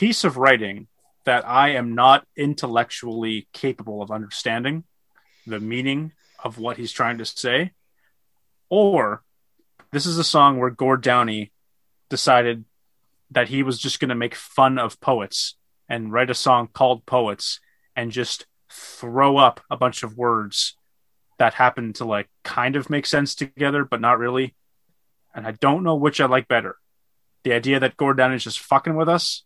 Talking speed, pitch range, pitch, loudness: 165 wpm, 115-140 Hz, 125 Hz, -21 LUFS